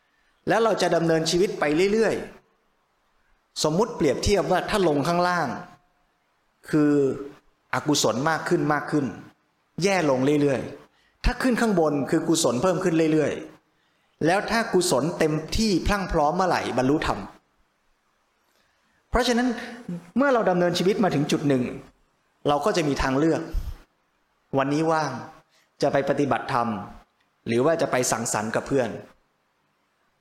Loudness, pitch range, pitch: -23 LUFS, 145-185 Hz, 160 Hz